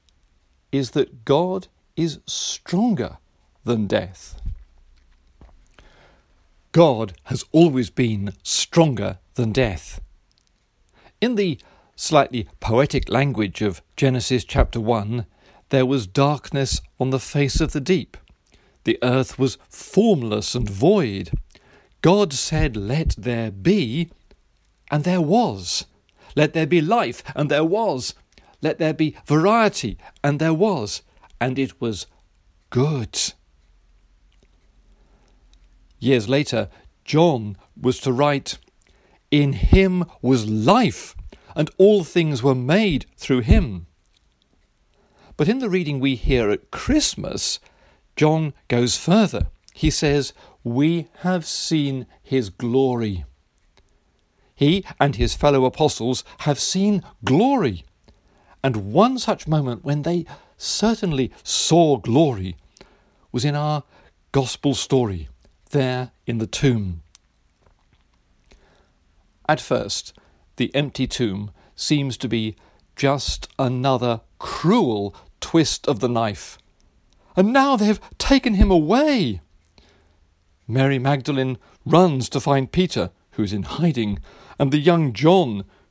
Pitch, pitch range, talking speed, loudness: 130 Hz, 100-155 Hz, 110 wpm, -21 LUFS